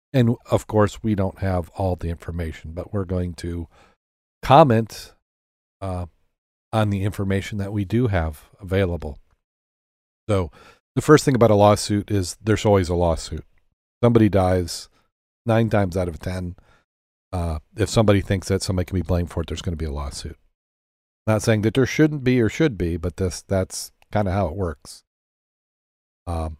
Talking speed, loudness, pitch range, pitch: 175 wpm, -22 LUFS, 80-105 Hz, 90 Hz